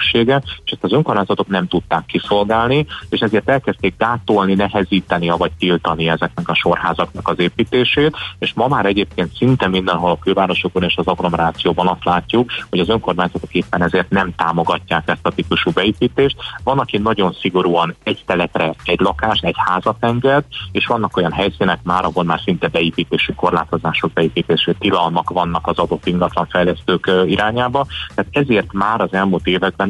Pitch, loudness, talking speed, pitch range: 95 Hz, -16 LUFS, 155 wpm, 90-105 Hz